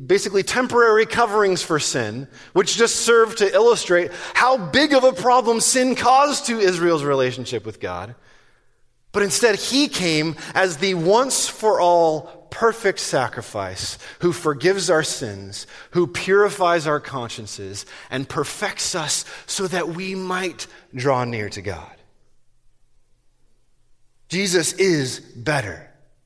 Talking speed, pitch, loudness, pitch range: 125 wpm, 175 Hz, -19 LUFS, 130-205 Hz